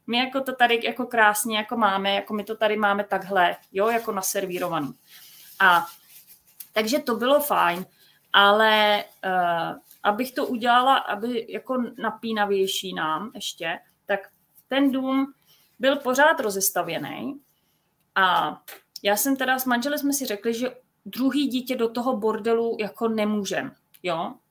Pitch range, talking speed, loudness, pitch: 200-255 Hz, 135 wpm, -23 LUFS, 220 Hz